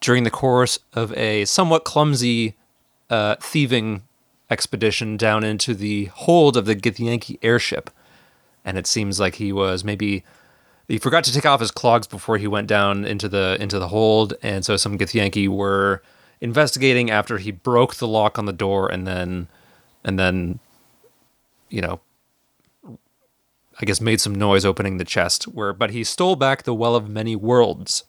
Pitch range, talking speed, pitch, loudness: 100-120 Hz, 170 wpm, 110 Hz, -20 LUFS